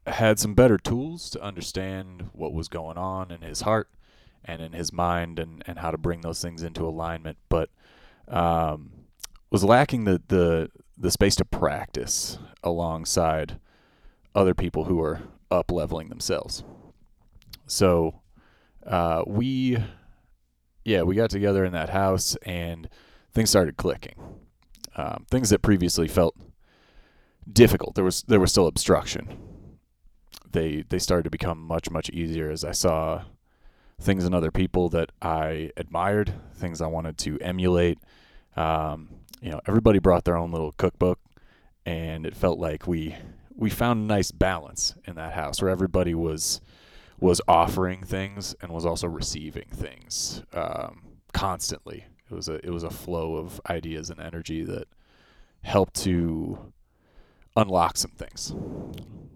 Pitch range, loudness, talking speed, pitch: 80-95 Hz, -25 LUFS, 145 wpm, 85 Hz